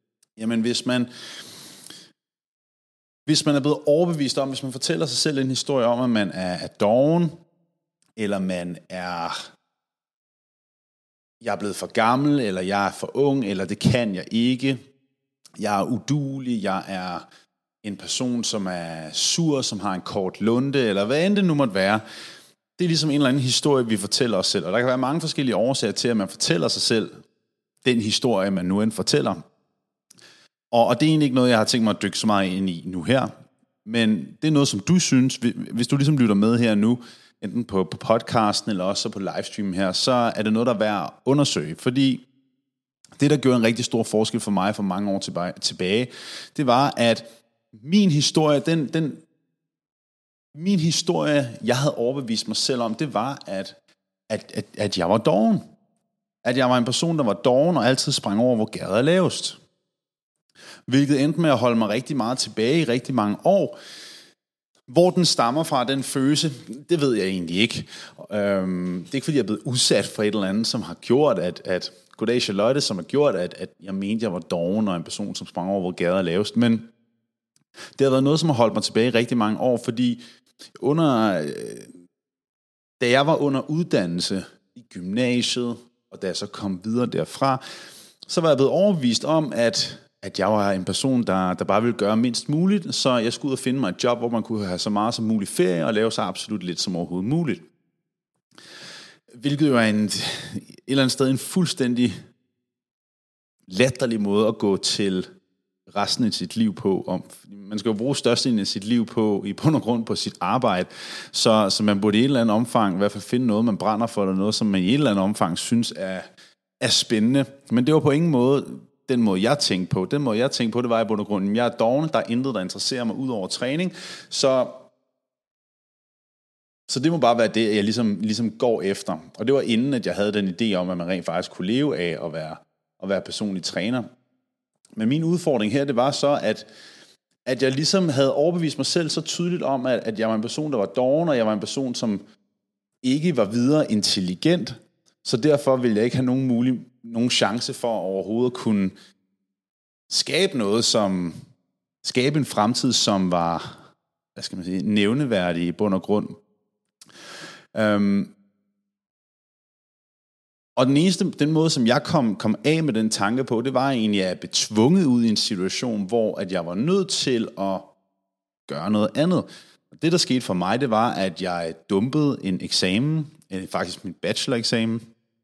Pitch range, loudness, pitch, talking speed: 100-140 Hz, -22 LUFS, 120 Hz, 200 wpm